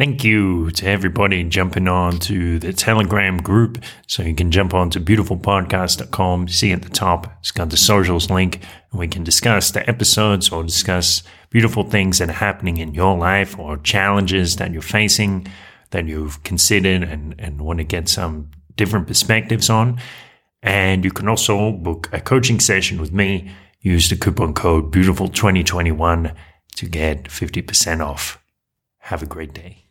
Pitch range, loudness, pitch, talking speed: 85-100 Hz, -17 LUFS, 95 Hz, 165 wpm